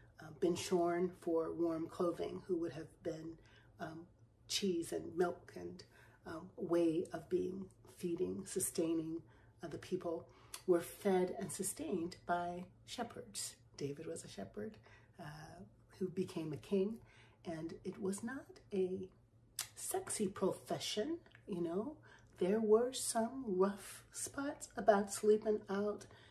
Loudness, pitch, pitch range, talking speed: -40 LUFS, 175 Hz, 160-195 Hz, 130 wpm